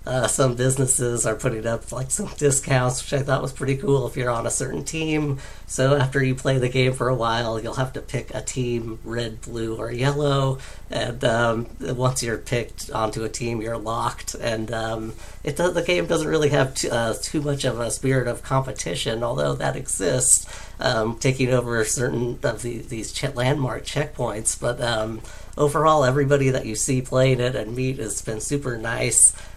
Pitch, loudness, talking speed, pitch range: 125 Hz, -23 LUFS, 195 wpm, 115-135 Hz